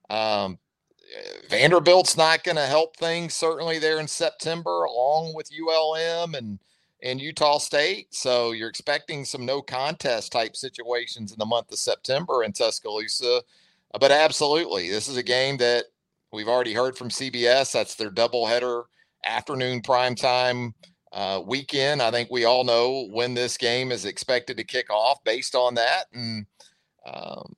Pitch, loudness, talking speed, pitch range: 130 Hz, -23 LUFS, 150 wpm, 120-160 Hz